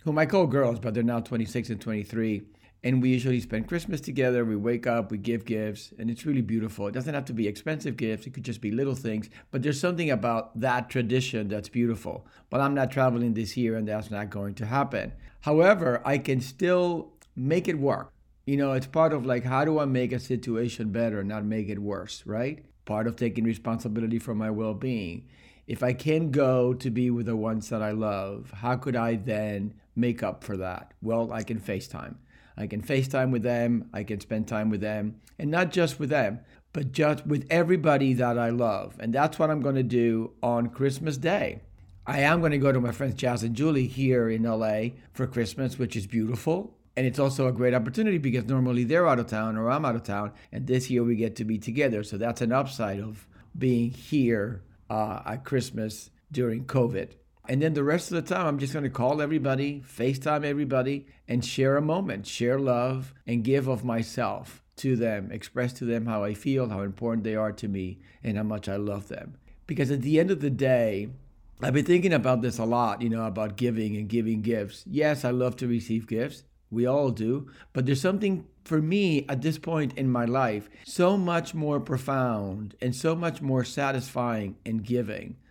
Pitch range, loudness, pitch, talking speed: 110-140 Hz, -28 LUFS, 125 Hz, 210 wpm